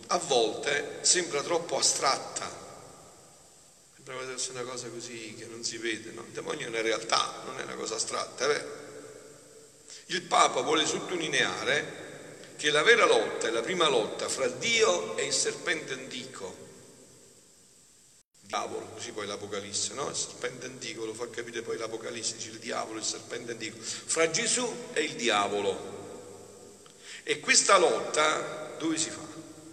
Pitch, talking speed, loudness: 160 Hz, 150 wpm, -28 LUFS